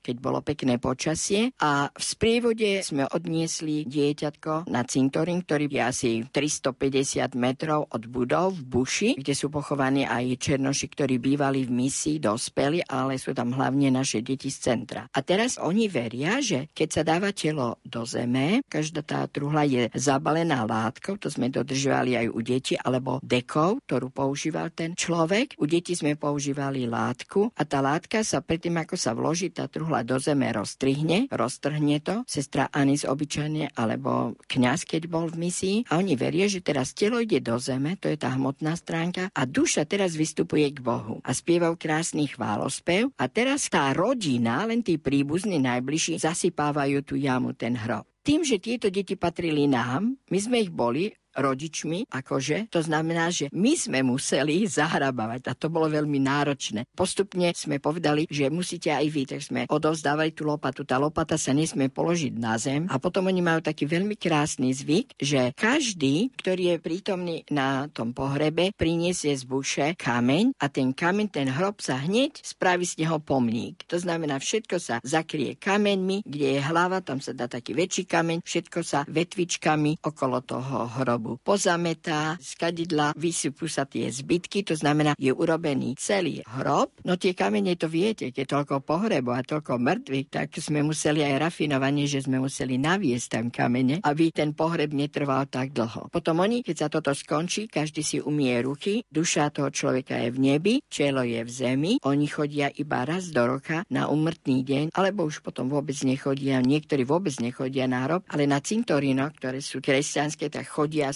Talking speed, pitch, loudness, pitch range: 170 wpm, 150 Hz, -26 LUFS, 135-170 Hz